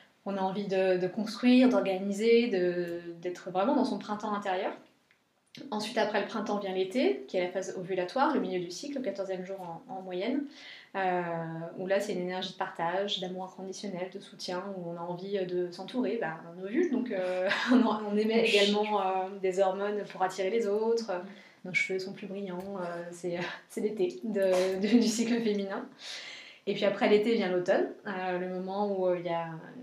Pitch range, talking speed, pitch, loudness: 185-210 Hz, 195 wpm, 195 Hz, -31 LUFS